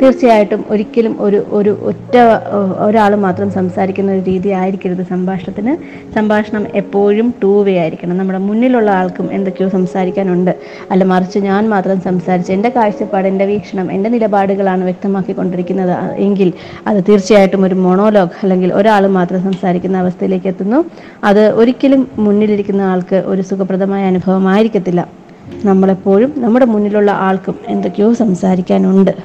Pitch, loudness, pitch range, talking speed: 195 Hz, -12 LUFS, 185-210 Hz, 115 wpm